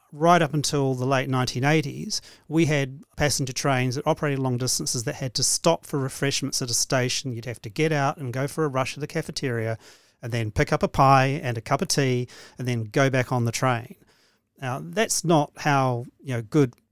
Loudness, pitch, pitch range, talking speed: -24 LUFS, 135 Hz, 125-150 Hz, 215 wpm